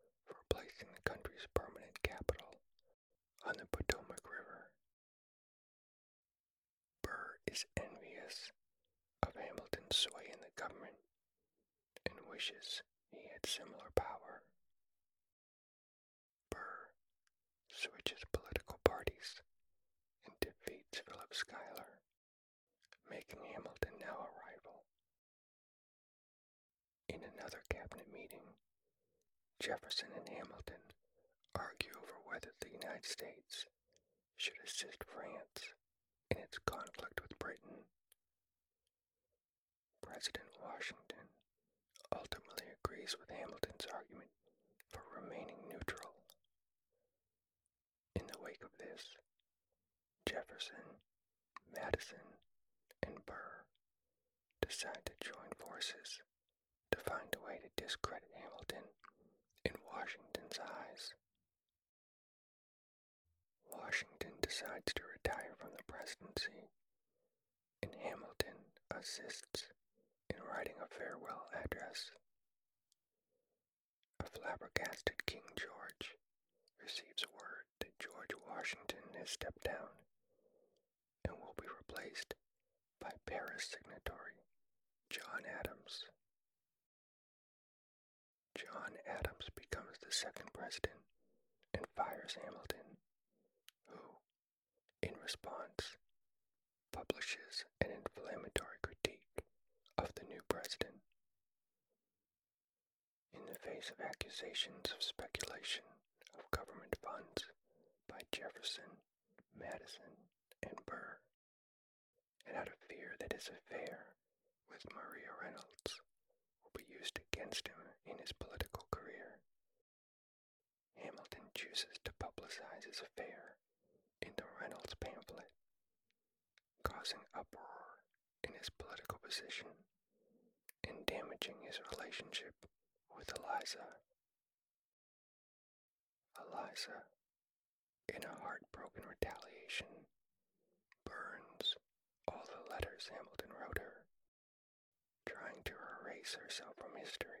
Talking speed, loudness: 90 wpm, -48 LUFS